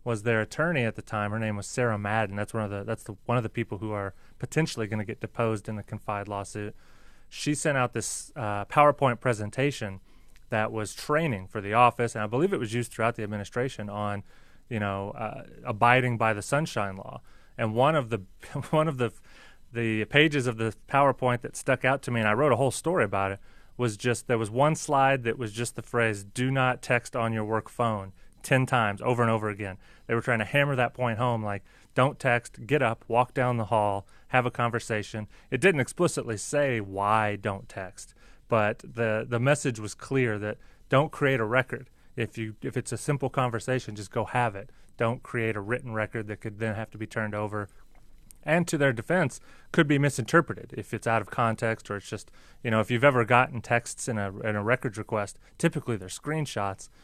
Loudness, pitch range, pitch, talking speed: -28 LUFS, 105-130 Hz, 115 Hz, 215 wpm